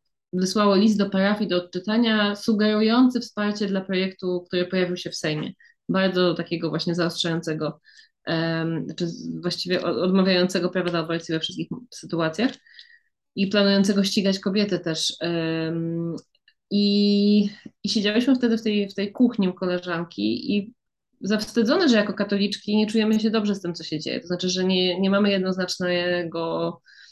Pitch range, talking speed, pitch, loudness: 175-215 Hz, 150 wpm, 190 Hz, -23 LUFS